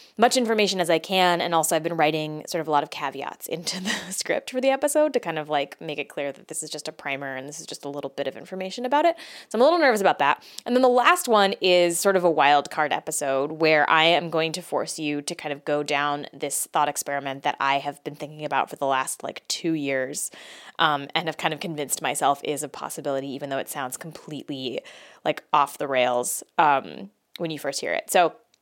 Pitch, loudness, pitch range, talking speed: 155 Hz, -24 LUFS, 145-175 Hz, 245 wpm